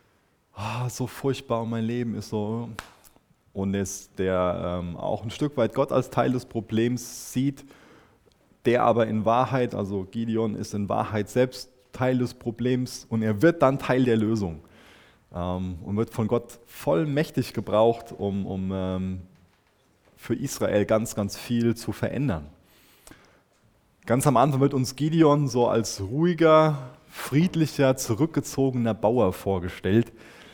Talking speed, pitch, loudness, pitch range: 140 wpm, 115 Hz, -25 LUFS, 105-130 Hz